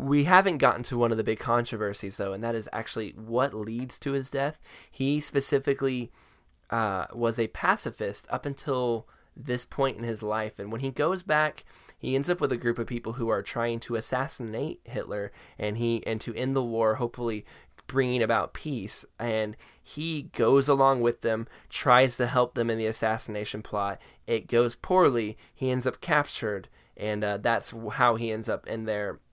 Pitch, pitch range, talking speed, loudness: 120 Hz, 110-135 Hz, 190 wpm, -28 LUFS